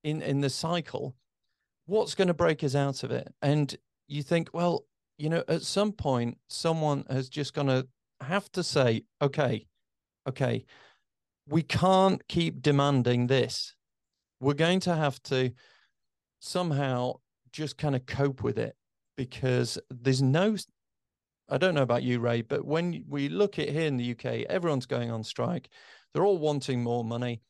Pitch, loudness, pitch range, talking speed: 140 Hz, -29 LUFS, 130-165 Hz, 165 wpm